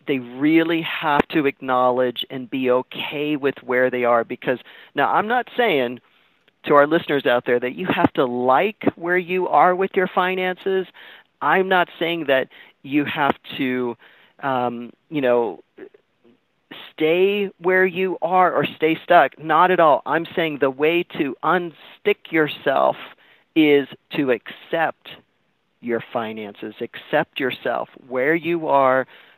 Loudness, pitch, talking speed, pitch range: -20 LUFS, 150 Hz, 150 wpm, 130-180 Hz